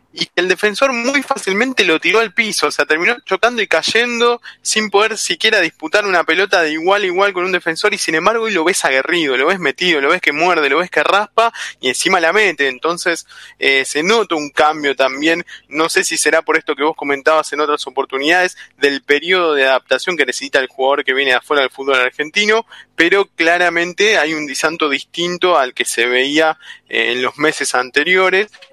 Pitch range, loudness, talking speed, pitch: 155-210 Hz, -14 LUFS, 210 wpm, 175 Hz